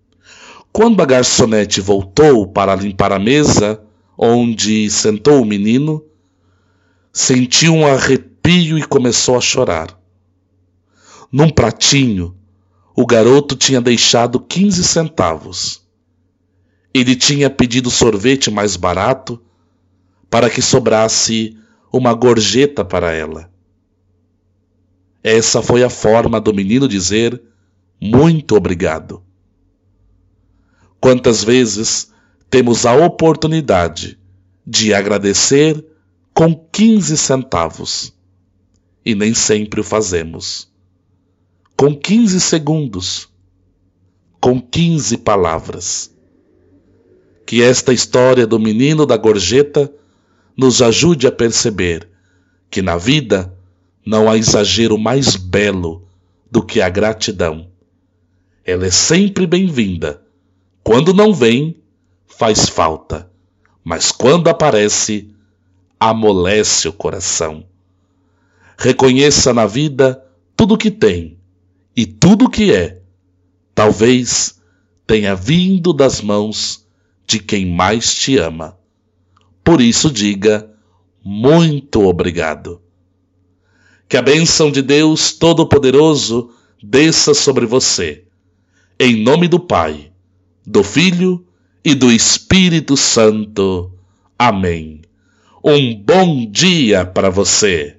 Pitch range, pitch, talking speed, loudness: 90-130 Hz, 105 Hz, 100 wpm, -12 LUFS